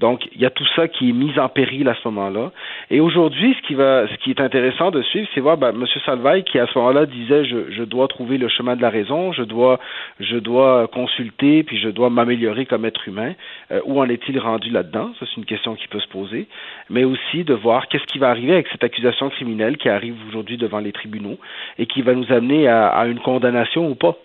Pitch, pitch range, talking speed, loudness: 125 Hz, 115-135 Hz, 245 wpm, -18 LUFS